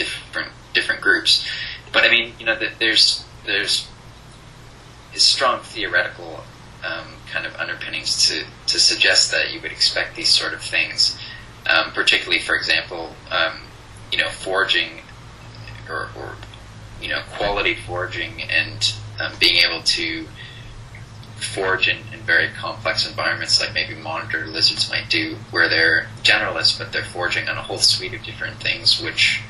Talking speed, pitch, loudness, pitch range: 150 wpm, 110 Hz, -18 LUFS, 110-115 Hz